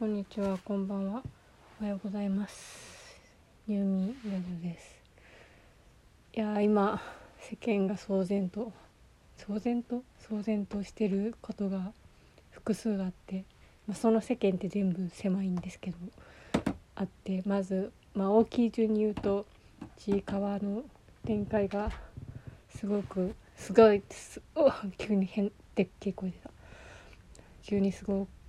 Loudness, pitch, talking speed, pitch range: -32 LUFS, 200 Hz, 255 characters per minute, 195-215 Hz